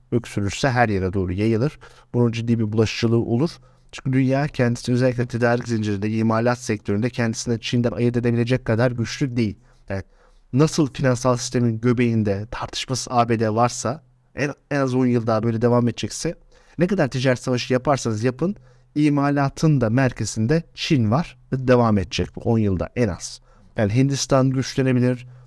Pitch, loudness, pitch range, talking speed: 120 Hz, -21 LUFS, 115-130 Hz, 150 wpm